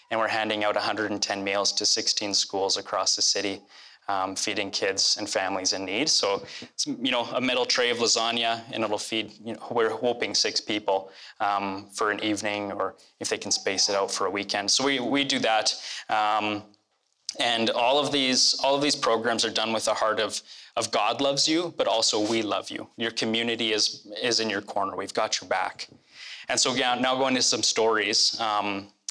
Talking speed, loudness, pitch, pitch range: 205 wpm, -25 LUFS, 110 Hz, 105-125 Hz